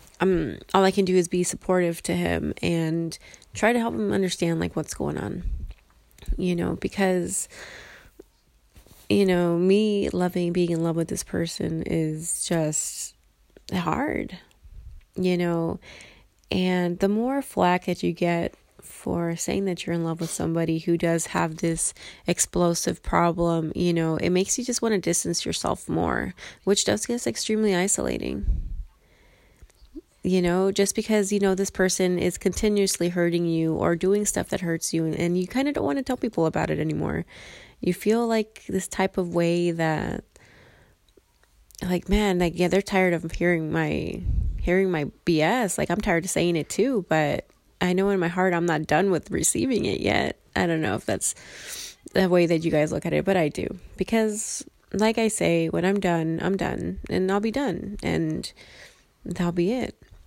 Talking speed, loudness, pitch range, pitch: 180 wpm, -25 LUFS, 165-195 Hz, 180 Hz